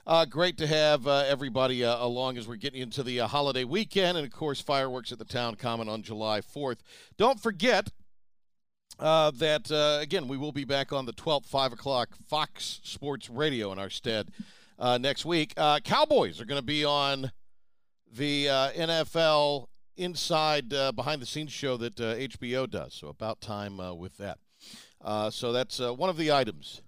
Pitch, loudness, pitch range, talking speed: 135 Hz, -29 LUFS, 120-150 Hz, 190 wpm